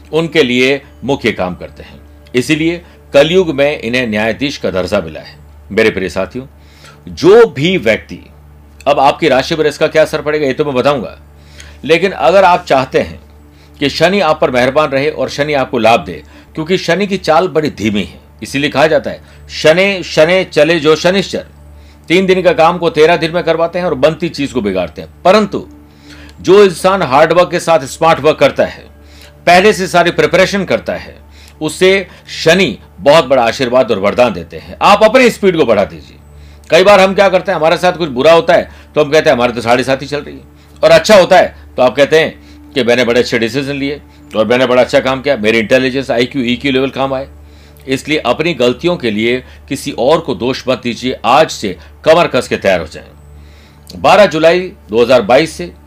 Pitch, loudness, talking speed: 130 Hz, -11 LUFS, 200 wpm